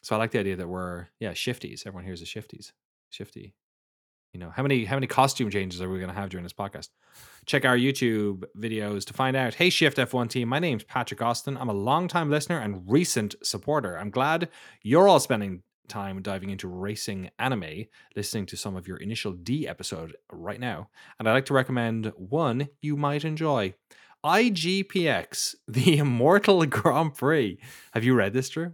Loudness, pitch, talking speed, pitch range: -26 LUFS, 120 Hz, 190 wpm, 100-140 Hz